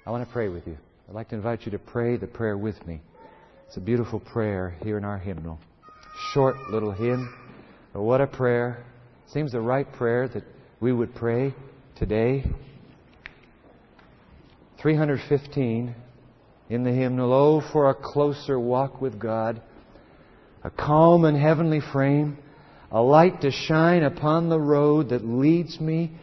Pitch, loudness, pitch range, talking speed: 125 Hz, -24 LUFS, 115-145 Hz, 155 wpm